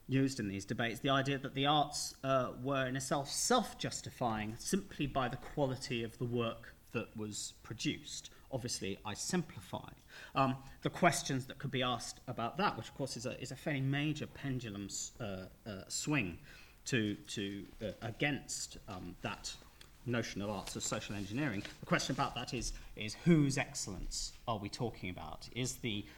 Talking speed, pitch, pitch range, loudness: 175 wpm, 125 Hz, 110-140 Hz, -38 LUFS